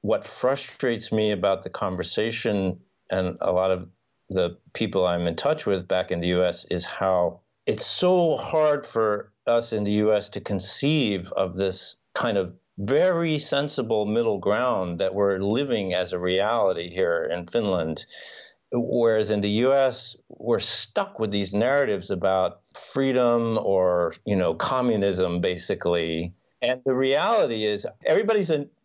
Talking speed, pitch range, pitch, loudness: 150 wpm, 95-130 Hz, 110 Hz, -24 LUFS